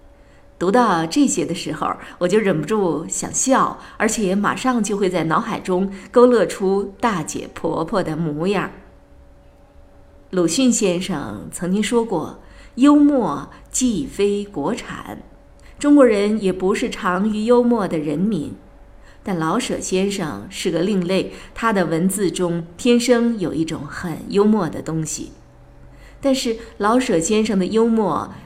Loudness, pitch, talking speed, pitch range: -19 LUFS, 195 Hz, 200 characters per minute, 170-230 Hz